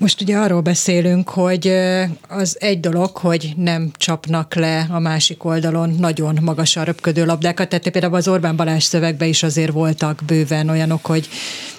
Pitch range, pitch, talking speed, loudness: 160-180 Hz, 165 Hz, 160 wpm, -17 LUFS